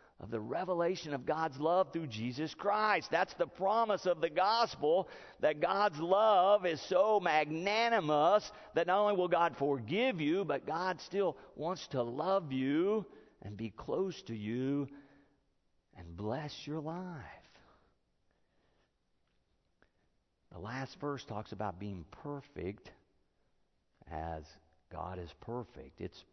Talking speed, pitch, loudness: 130 wpm, 150 Hz, -34 LUFS